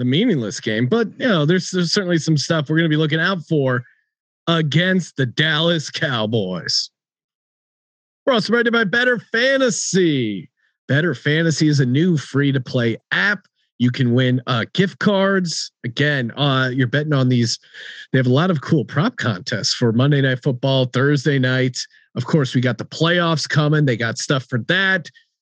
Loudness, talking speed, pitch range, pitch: -18 LUFS, 170 wpm, 130-175 Hz, 150 Hz